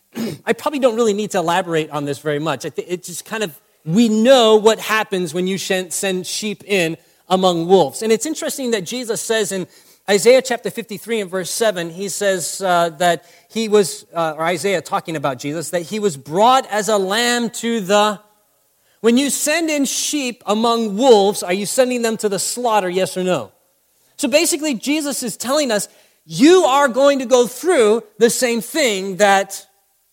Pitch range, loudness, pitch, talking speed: 185-235 Hz, -17 LUFS, 210 Hz, 185 wpm